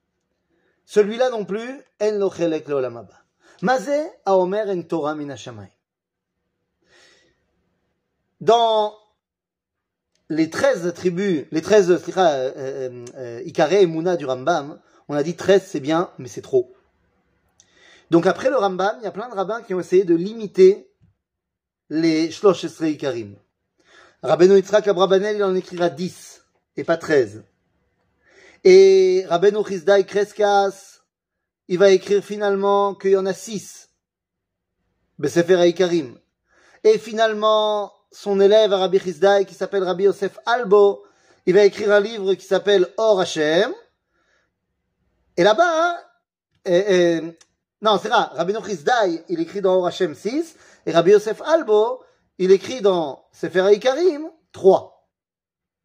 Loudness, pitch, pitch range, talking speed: -19 LUFS, 195 Hz, 170-215 Hz, 130 wpm